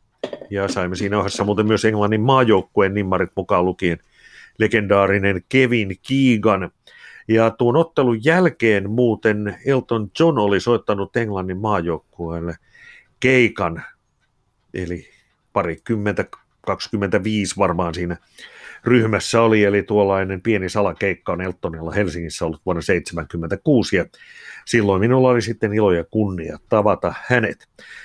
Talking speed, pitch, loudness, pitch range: 115 wpm, 105 Hz, -19 LUFS, 95-115 Hz